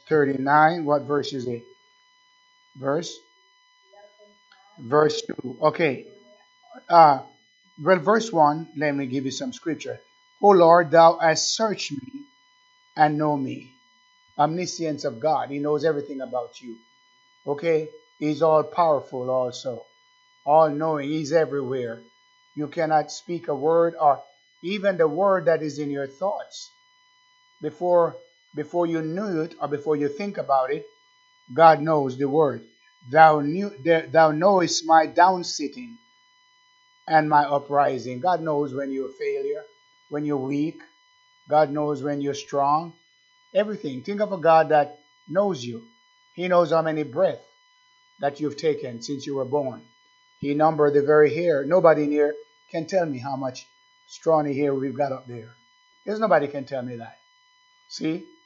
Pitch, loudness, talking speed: 165 Hz, -22 LUFS, 150 wpm